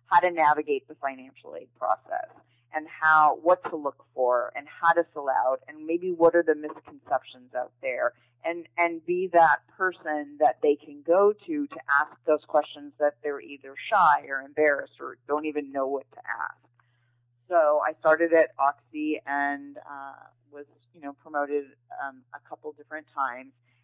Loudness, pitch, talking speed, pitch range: -26 LUFS, 150 Hz, 175 wpm, 135-165 Hz